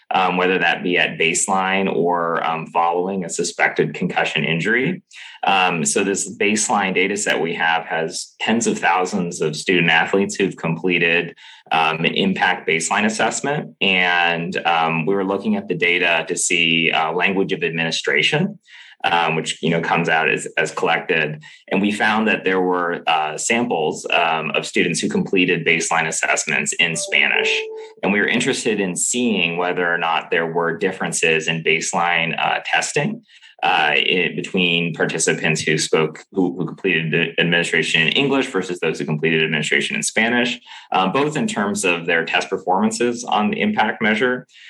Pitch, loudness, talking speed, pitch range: 90 Hz, -18 LUFS, 165 wpm, 80-105 Hz